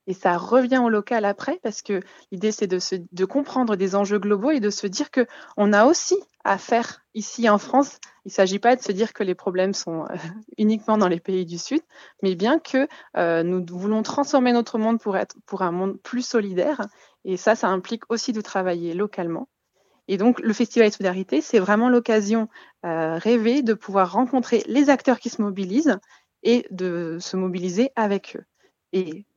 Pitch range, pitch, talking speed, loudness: 190-245 Hz, 215 Hz, 200 wpm, -22 LUFS